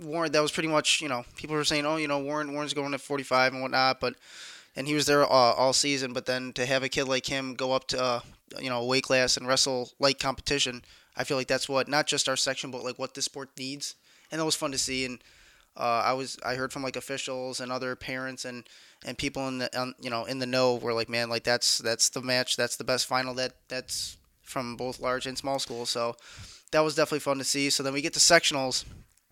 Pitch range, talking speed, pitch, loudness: 125-140 Hz, 255 wpm, 130 Hz, -27 LUFS